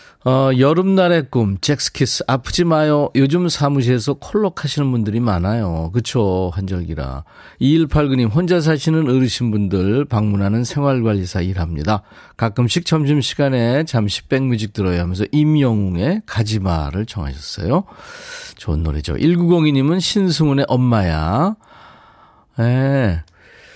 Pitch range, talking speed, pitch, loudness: 100-150 Hz, 280 characters per minute, 125 Hz, -17 LUFS